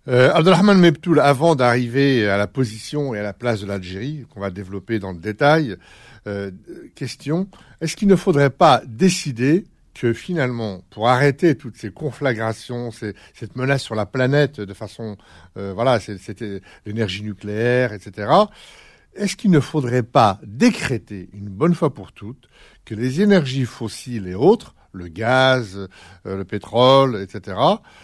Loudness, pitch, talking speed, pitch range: -19 LUFS, 120 Hz, 155 wpm, 105-145 Hz